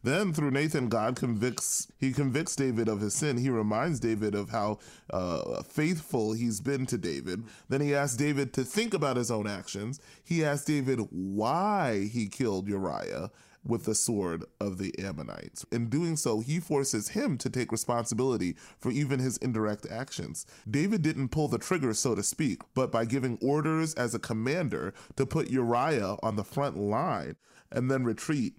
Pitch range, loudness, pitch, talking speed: 110-145 Hz, -30 LUFS, 125 Hz, 175 wpm